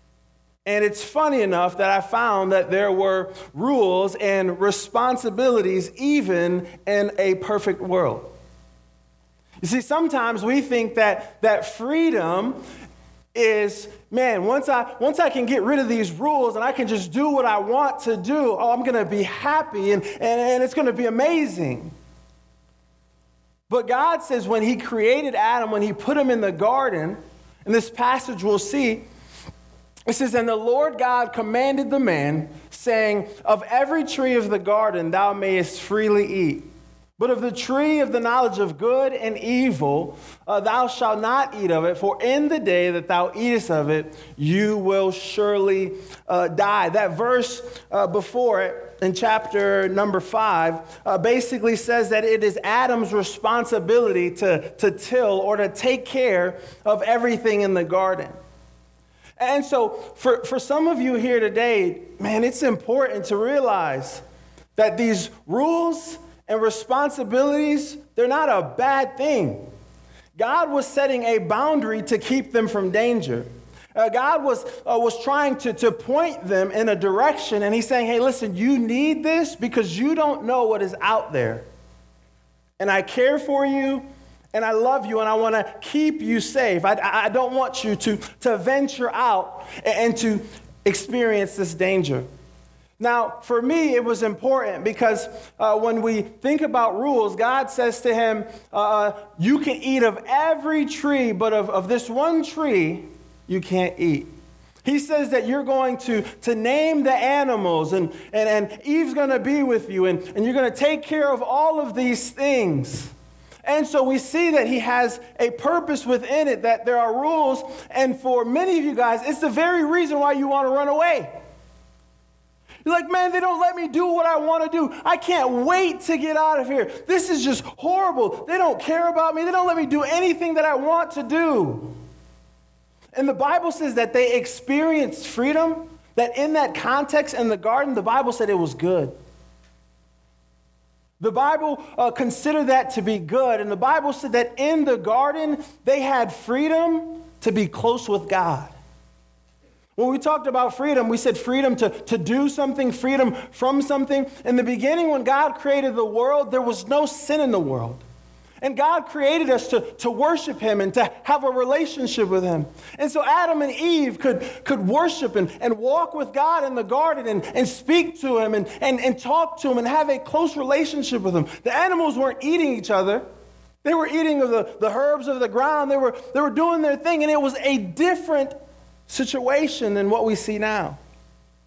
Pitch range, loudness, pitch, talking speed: 205-285 Hz, -21 LUFS, 245 Hz, 180 wpm